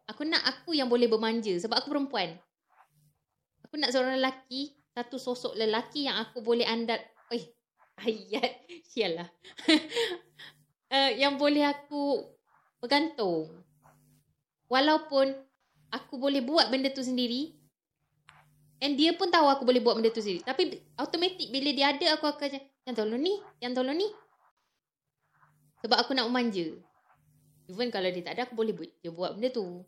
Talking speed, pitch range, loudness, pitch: 155 wpm, 220-285 Hz, -29 LUFS, 250 Hz